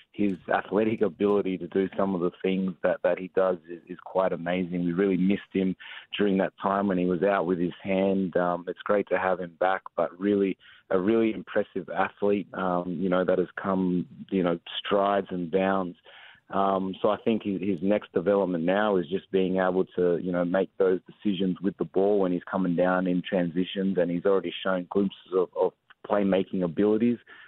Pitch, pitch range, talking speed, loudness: 95 Hz, 90-100 Hz, 200 wpm, -27 LUFS